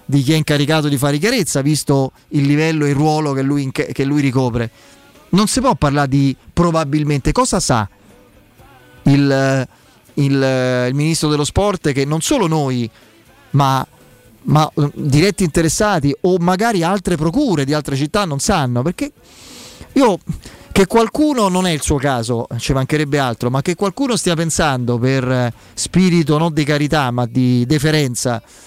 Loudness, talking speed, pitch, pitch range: -16 LUFS, 155 wpm, 145 Hz, 130-165 Hz